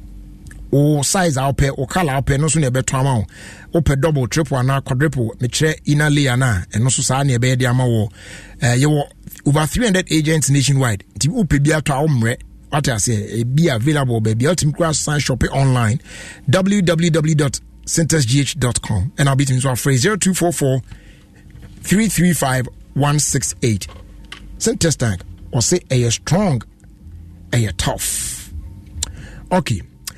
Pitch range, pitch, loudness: 115-155 Hz, 135 Hz, -17 LUFS